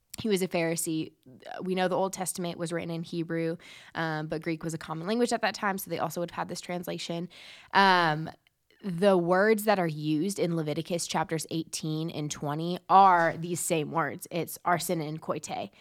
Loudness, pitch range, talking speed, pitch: -29 LUFS, 160-185 Hz, 195 wpm, 170 Hz